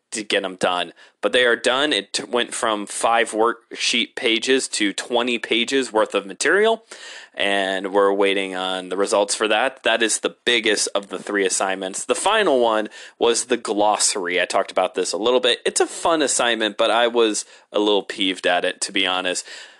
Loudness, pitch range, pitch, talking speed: -20 LUFS, 100-130 Hz, 115 Hz, 195 wpm